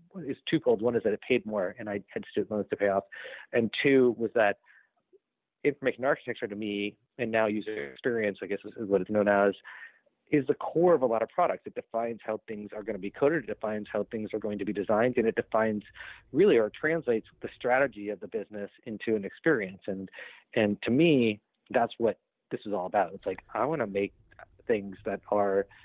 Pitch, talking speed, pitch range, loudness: 105 Hz, 215 wpm, 100-115 Hz, -29 LUFS